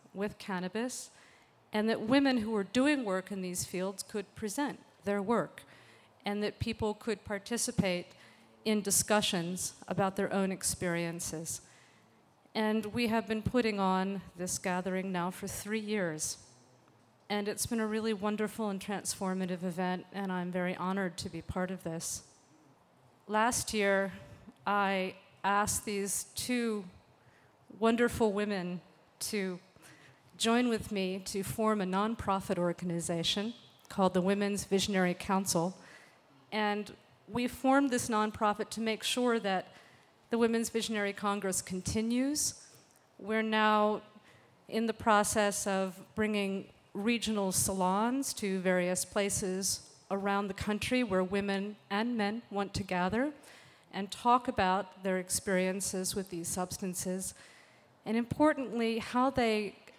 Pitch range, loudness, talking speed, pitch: 185-220 Hz, -33 LUFS, 125 wpm, 200 Hz